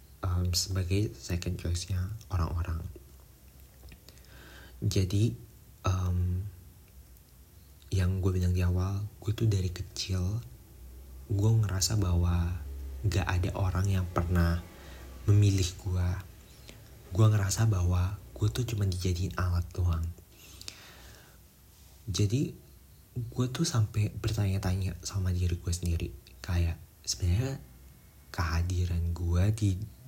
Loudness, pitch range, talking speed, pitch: -31 LUFS, 85-100 Hz, 100 wpm, 90 Hz